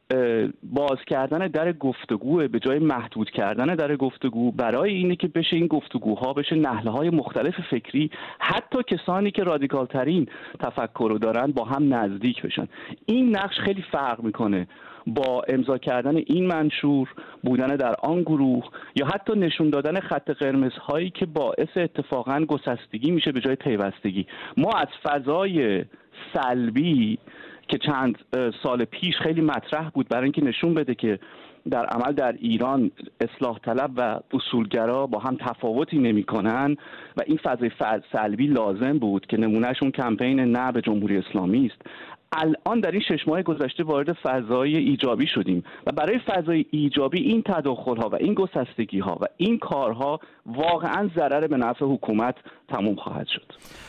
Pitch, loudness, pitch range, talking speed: 140 Hz, -24 LUFS, 125-165 Hz, 155 wpm